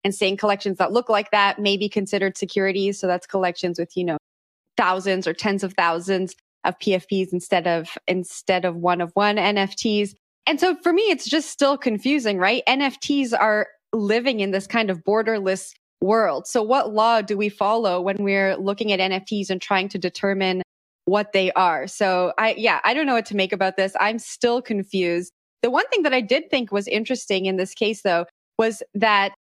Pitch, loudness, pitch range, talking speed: 200 Hz, -21 LUFS, 190-225 Hz, 195 wpm